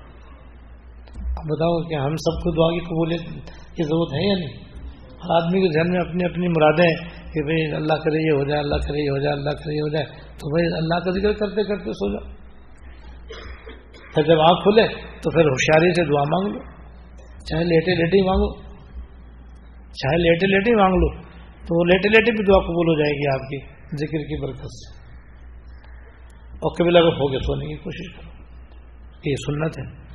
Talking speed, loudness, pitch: 195 wpm, -20 LUFS, 155 Hz